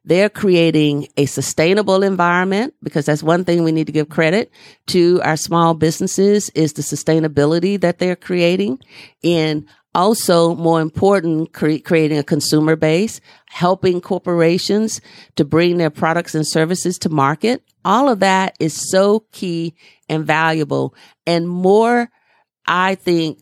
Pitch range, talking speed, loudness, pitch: 155-190 Hz, 140 wpm, -16 LUFS, 170 Hz